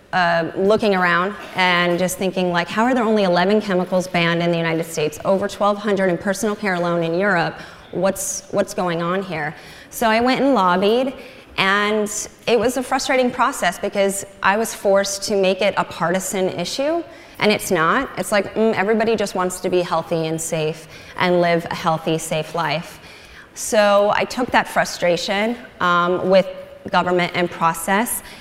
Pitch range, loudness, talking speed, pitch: 175-210 Hz, -19 LUFS, 175 wpm, 190 Hz